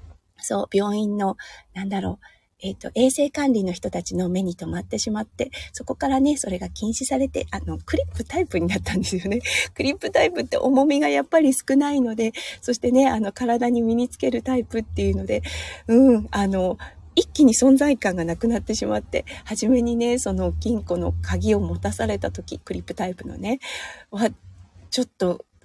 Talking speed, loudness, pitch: 365 characters per minute, -22 LUFS, 210 Hz